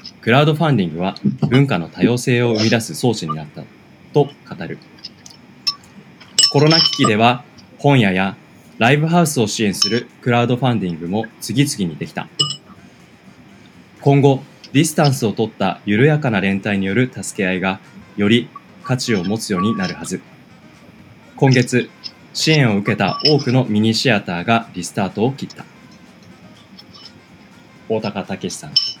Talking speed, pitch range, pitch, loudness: 295 characters per minute, 105-140 Hz, 120 Hz, -17 LUFS